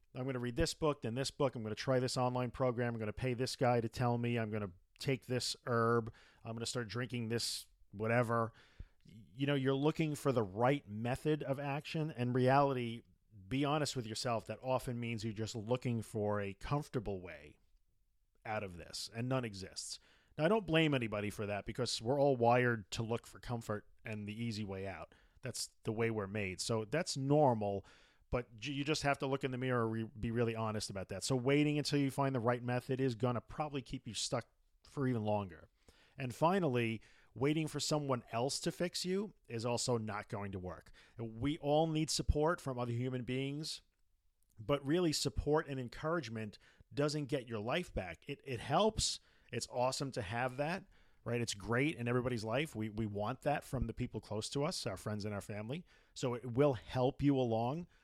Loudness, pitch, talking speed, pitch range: -37 LUFS, 125 Hz, 205 wpm, 110-140 Hz